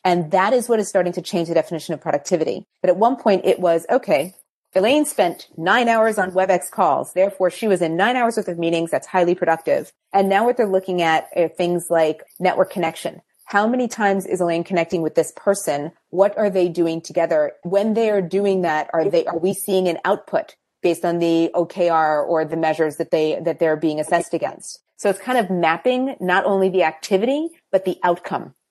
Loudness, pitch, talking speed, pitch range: -20 LUFS, 180 Hz, 210 wpm, 165-200 Hz